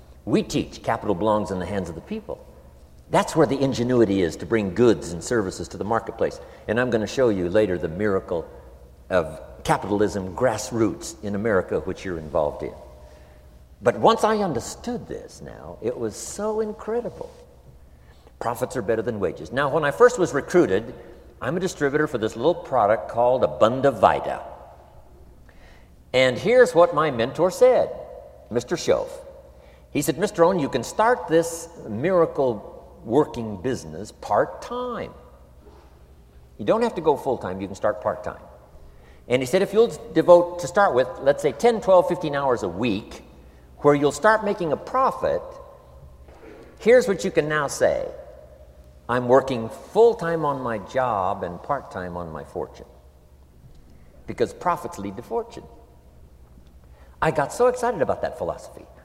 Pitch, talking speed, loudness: 115 Hz, 160 wpm, -23 LUFS